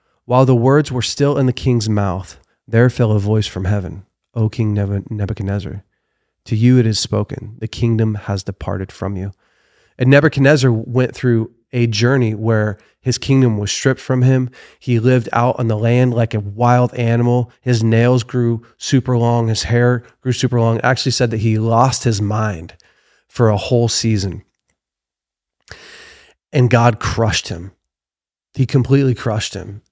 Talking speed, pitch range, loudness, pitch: 165 wpm, 105-125 Hz, -16 LUFS, 115 Hz